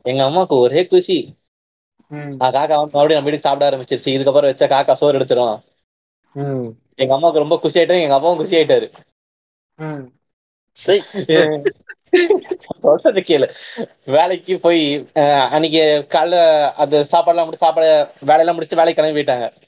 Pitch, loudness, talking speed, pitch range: 155 Hz, -15 LUFS, 120 wpm, 145-175 Hz